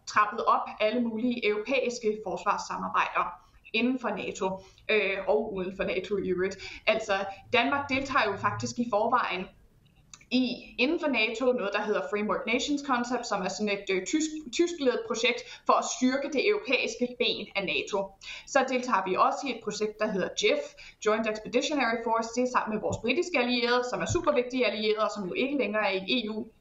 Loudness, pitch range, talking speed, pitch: -28 LUFS, 200-250 Hz, 185 wpm, 225 Hz